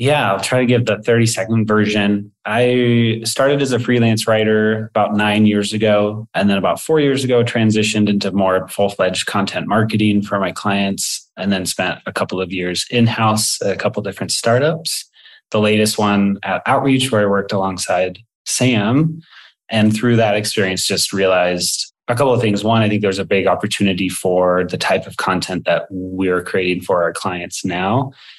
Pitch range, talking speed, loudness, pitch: 95-115 Hz, 180 wpm, -16 LUFS, 105 Hz